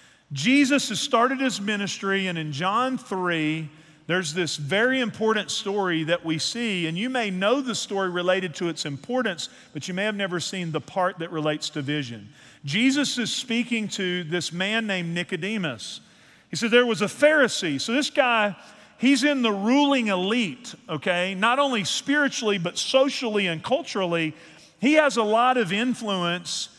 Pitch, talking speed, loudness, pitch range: 200 Hz, 170 wpm, -24 LUFS, 175-240 Hz